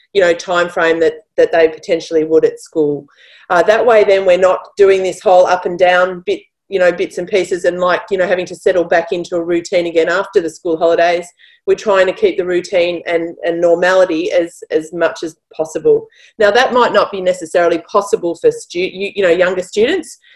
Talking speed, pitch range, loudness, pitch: 215 wpm, 170-215 Hz, -14 LUFS, 180 Hz